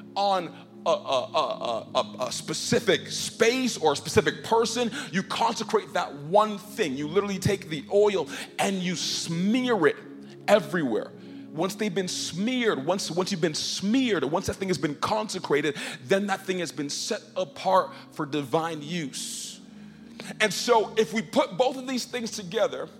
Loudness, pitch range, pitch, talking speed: -26 LUFS, 170-225 Hz, 195 Hz, 160 wpm